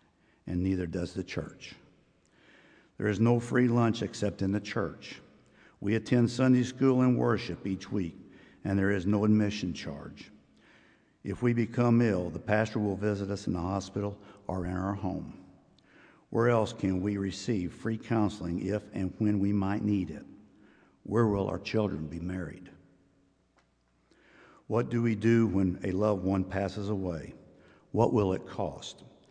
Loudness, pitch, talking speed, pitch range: -30 LUFS, 100 Hz, 160 wpm, 95-110 Hz